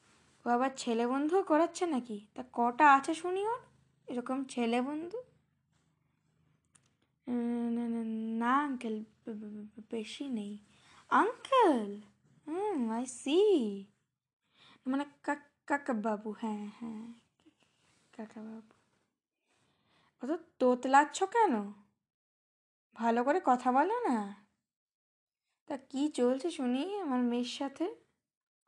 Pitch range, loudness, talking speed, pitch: 230-295 Hz, -32 LUFS, 80 wpm, 255 Hz